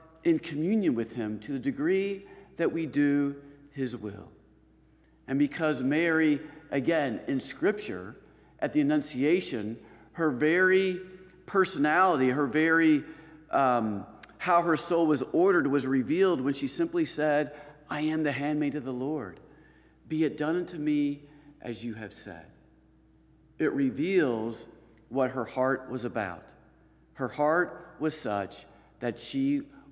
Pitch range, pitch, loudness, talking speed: 130-170 Hz, 150 Hz, -28 LUFS, 135 wpm